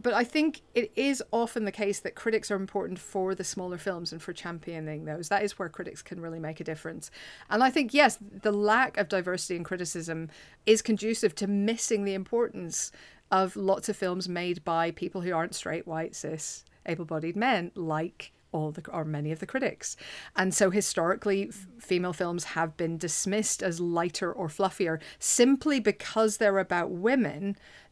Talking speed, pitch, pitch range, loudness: 180 wpm, 190 Hz, 170-210 Hz, -29 LUFS